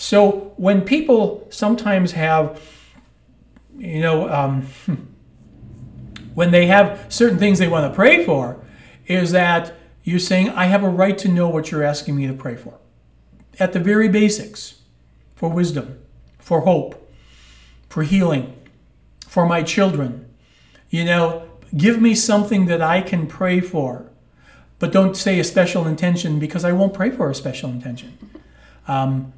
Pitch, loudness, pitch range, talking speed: 170 Hz, -18 LUFS, 135-190 Hz, 150 wpm